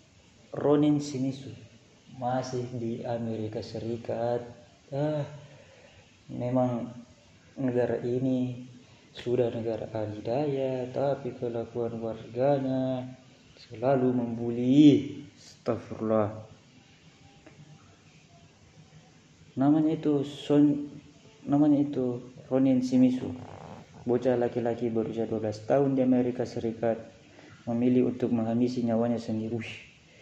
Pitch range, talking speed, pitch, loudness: 115-135 Hz, 80 wpm, 125 Hz, -28 LUFS